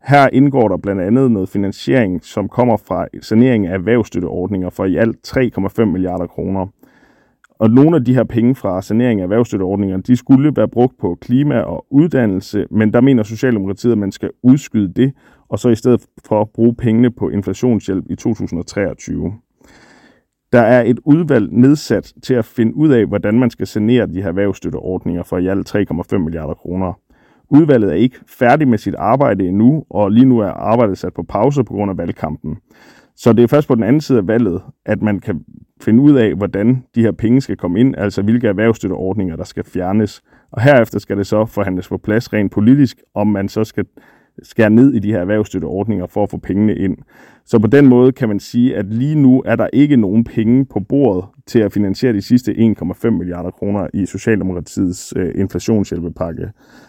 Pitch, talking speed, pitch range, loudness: 110 Hz, 195 wpm, 95-125 Hz, -15 LUFS